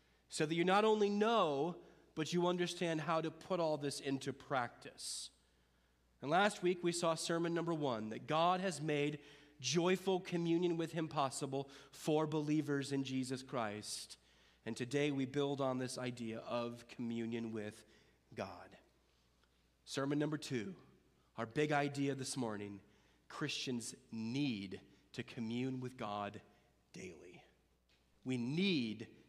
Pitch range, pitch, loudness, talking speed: 110-155 Hz, 135 Hz, -39 LUFS, 135 wpm